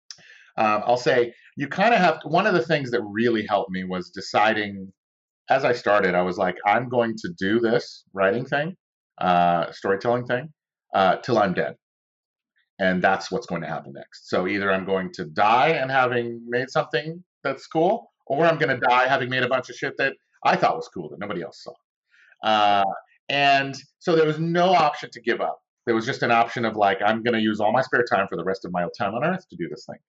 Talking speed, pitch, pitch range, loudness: 225 wpm, 120 Hz, 105-140 Hz, -23 LUFS